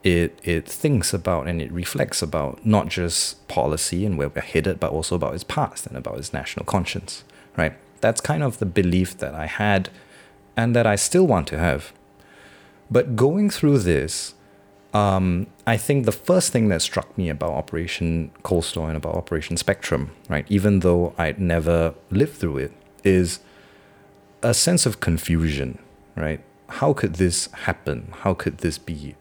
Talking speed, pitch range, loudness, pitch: 170 wpm, 85-105 Hz, -22 LUFS, 95 Hz